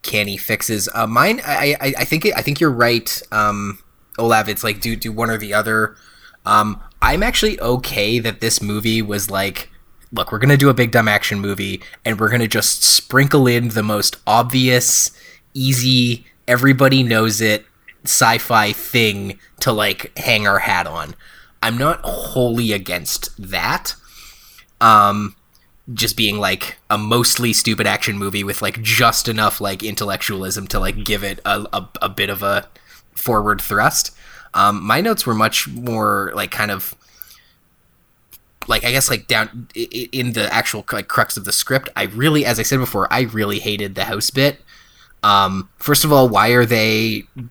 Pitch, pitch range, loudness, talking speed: 110 Hz, 105-125 Hz, -16 LUFS, 170 wpm